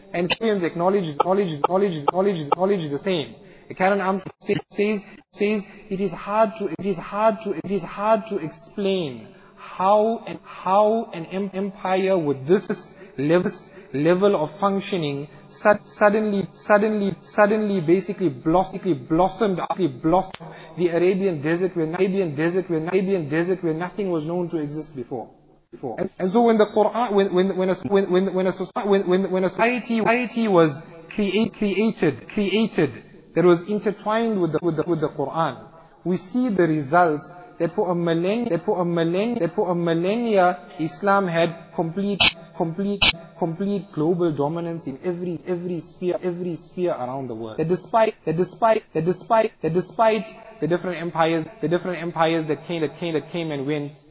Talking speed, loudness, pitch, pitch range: 160 wpm, -22 LUFS, 185 Hz, 165-200 Hz